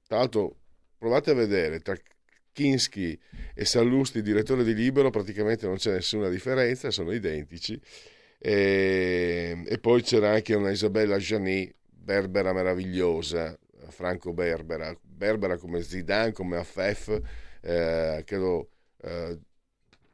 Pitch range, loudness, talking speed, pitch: 85-110 Hz, -27 LUFS, 120 wpm, 95 Hz